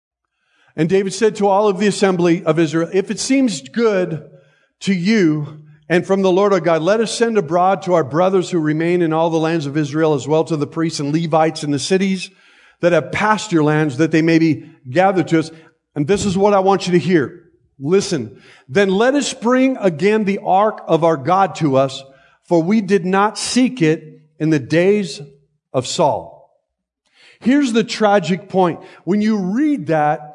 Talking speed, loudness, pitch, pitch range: 200 wpm, -16 LUFS, 175 Hz, 160-200 Hz